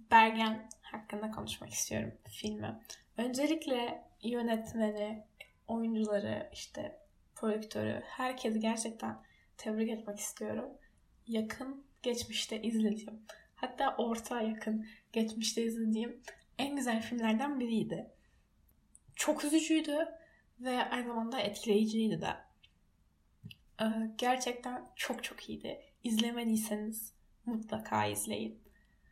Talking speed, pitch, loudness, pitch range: 85 wpm, 225 Hz, -36 LUFS, 210-240 Hz